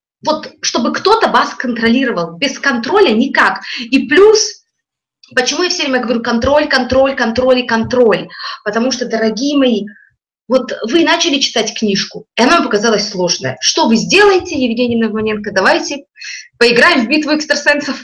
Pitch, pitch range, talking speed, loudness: 260 Hz, 230-300 Hz, 145 wpm, -12 LUFS